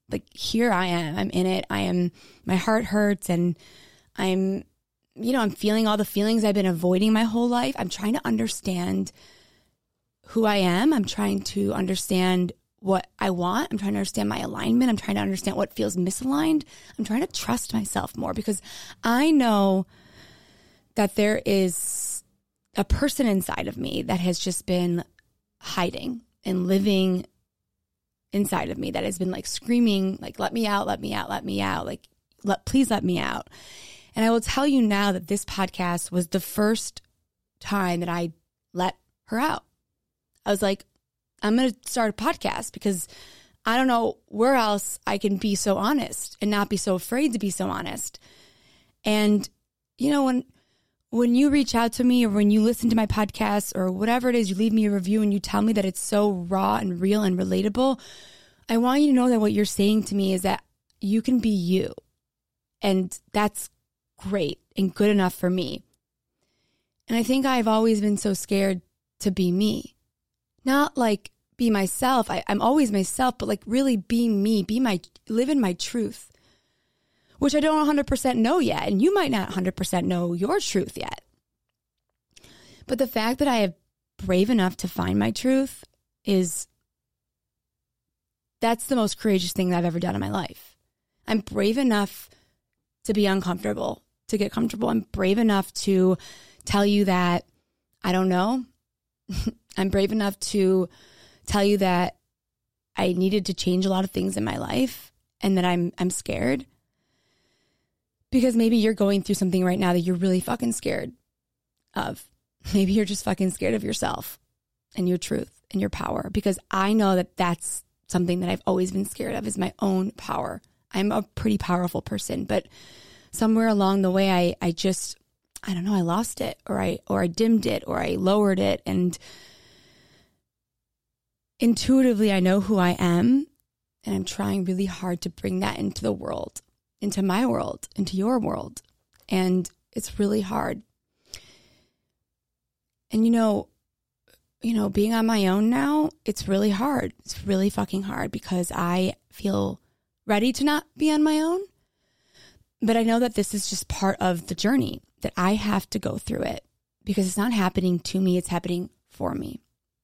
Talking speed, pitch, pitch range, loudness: 180 wpm, 200 Hz, 185-230 Hz, -24 LUFS